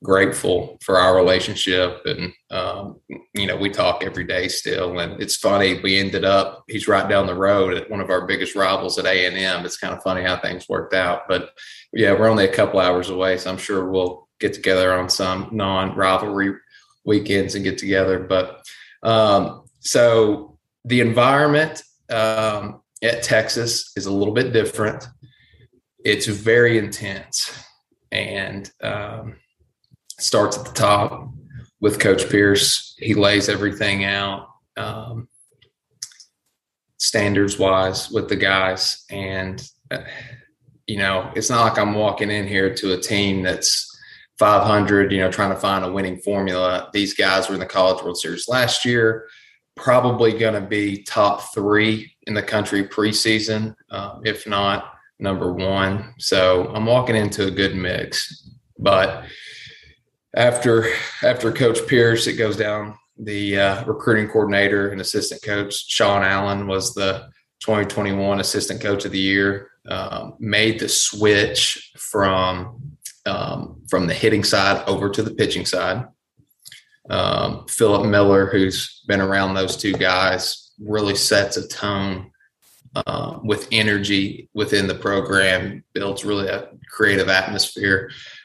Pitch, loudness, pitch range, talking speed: 100 Hz, -19 LUFS, 95-110 Hz, 145 wpm